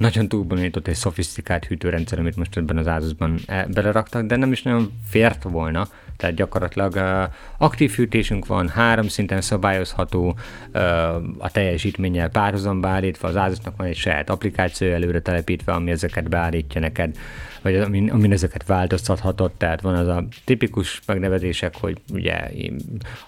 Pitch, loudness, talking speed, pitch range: 95 Hz, -22 LUFS, 145 wpm, 85-105 Hz